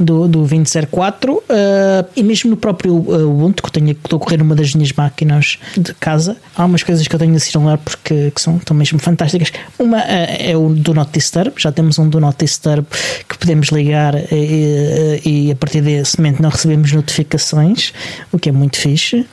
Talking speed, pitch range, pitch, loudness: 210 wpm, 150-170 Hz, 155 Hz, -13 LUFS